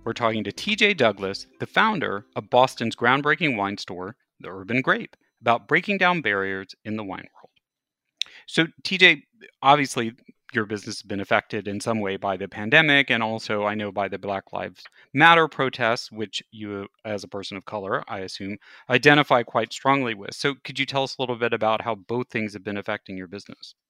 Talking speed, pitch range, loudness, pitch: 195 wpm, 100-135 Hz, -23 LUFS, 115 Hz